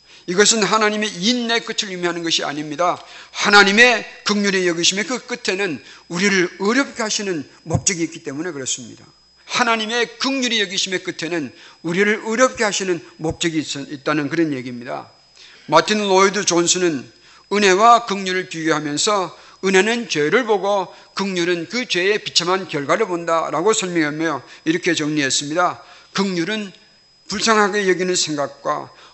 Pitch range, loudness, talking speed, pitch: 170-215 Hz, -18 LUFS, 335 characters per minute, 190 Hz